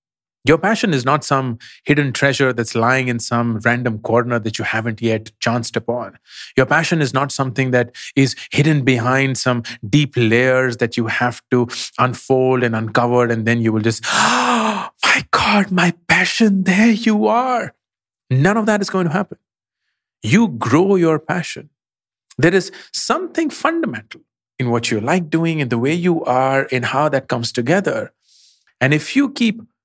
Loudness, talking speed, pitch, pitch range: -17 LUFS, 170 wpm, 130 Hz, 120-165 Hz